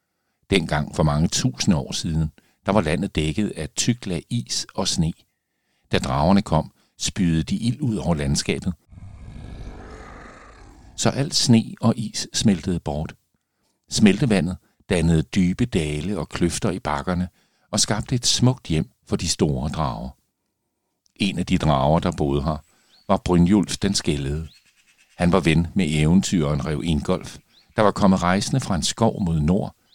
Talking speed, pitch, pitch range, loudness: 150 wpm, 85 Hz, 80-100 Hz, -22 LUFS